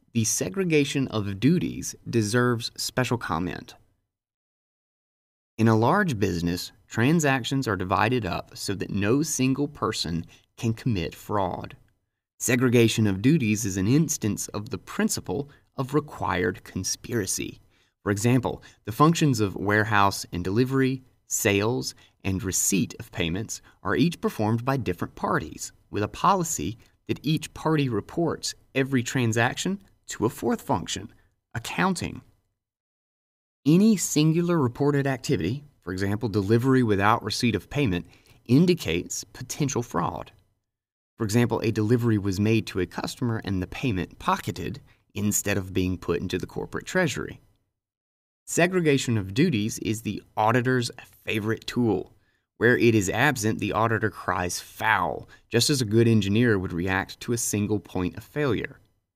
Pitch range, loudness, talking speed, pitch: 100-130 Hz, -25 LUFS, 135 wpm, 115 Hz